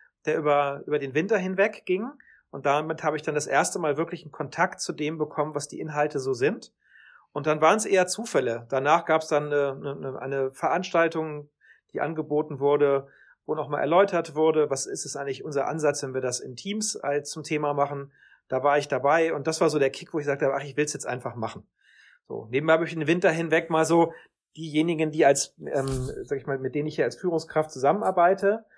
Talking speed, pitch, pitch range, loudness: 215 wpm, 155 Hz, 145-165 Hz, -26 LUFS